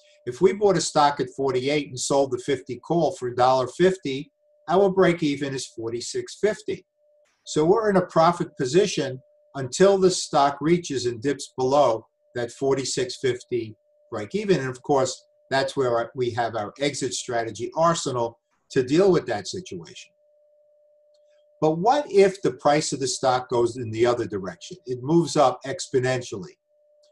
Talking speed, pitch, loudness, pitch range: 150 wpm, 155 Hz, -23 LUFS, 130-205 Hz